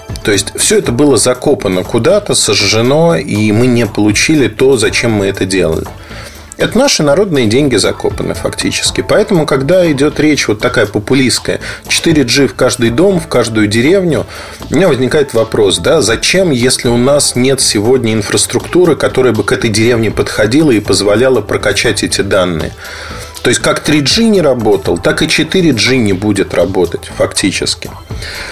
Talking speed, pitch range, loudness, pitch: 155 wpm, 110-160 Hz, -10 LUFS, 130 Hz